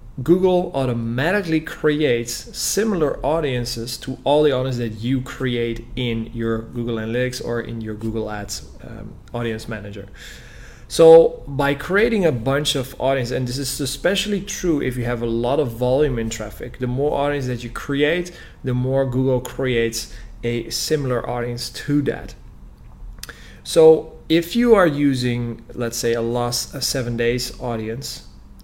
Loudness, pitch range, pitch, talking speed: -20 LUFS, 115-145 Hz, 125 Hz, 155 wpm